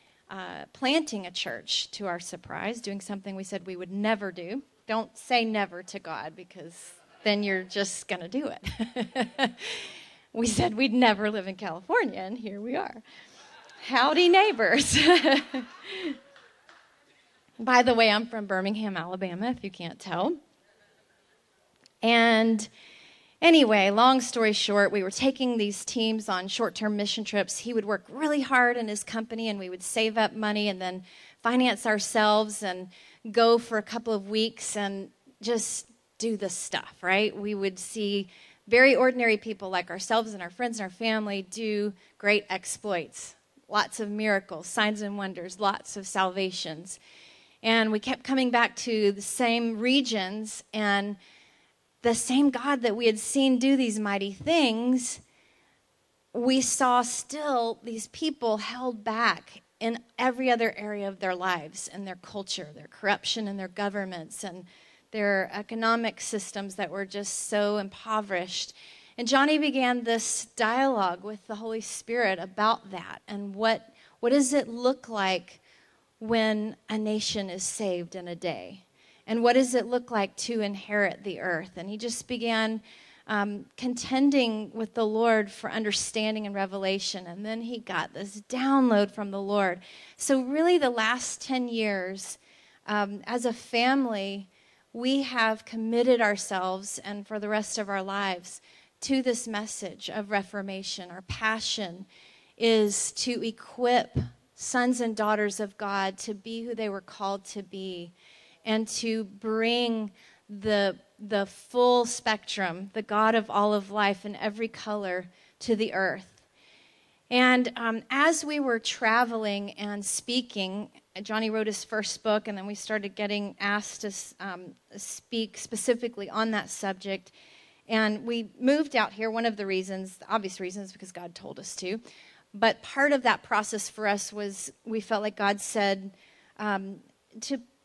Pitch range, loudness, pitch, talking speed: 195-235 Hz, -27 LUFS, 215 Hz, 155 wpm